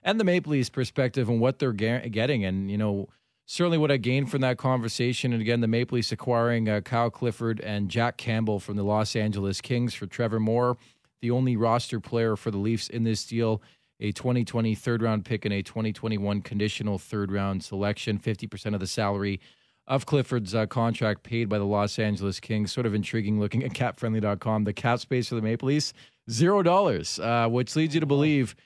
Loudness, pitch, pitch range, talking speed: -27 LUFS, 115 Hz, 105-125 Hz, 200 wpm